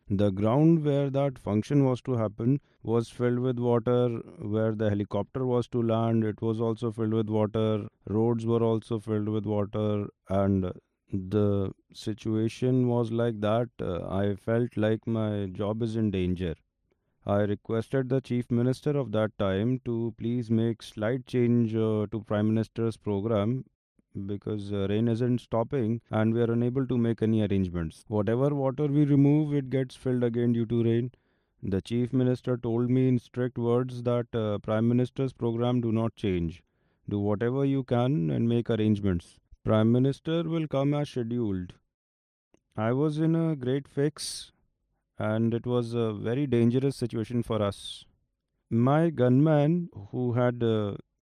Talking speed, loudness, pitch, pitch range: 160 wpm, -28 LUFS, 115 Hz, 105-125 Hz